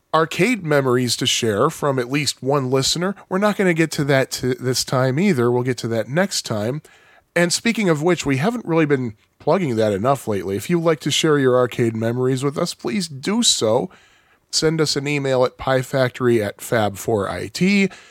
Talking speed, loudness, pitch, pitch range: 200 wpm, -19 LUFS, 140 Hz, 125-170 Hz